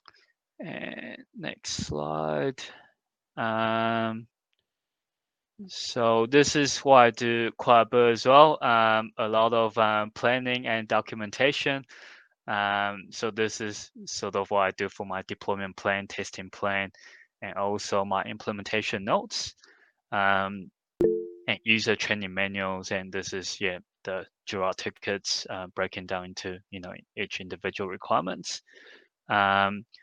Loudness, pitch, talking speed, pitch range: -26 LUFS, 105 Hz, 130 wpm, 100-115 Hz